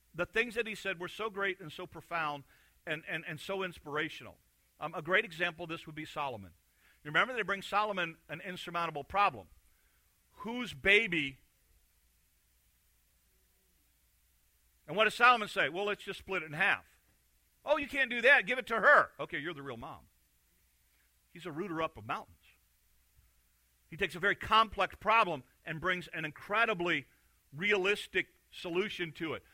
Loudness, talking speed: -32 LUFS, 165 wpm